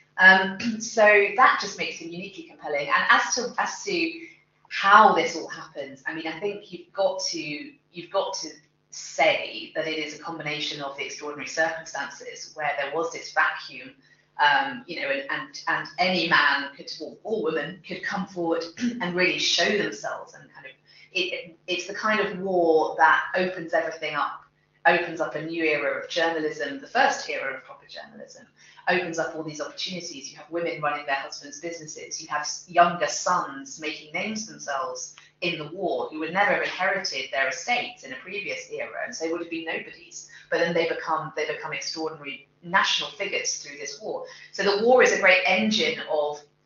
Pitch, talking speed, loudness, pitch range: 170 Hz, 190 wpm, -24 LUFS, 155-200 Hz